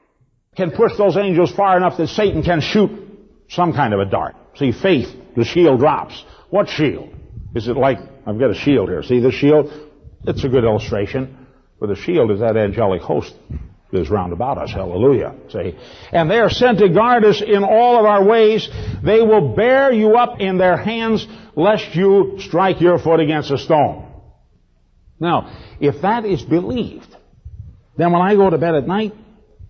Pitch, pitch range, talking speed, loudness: 175 Hz, 130-205 Hz, 185 wpm, -16 LUFS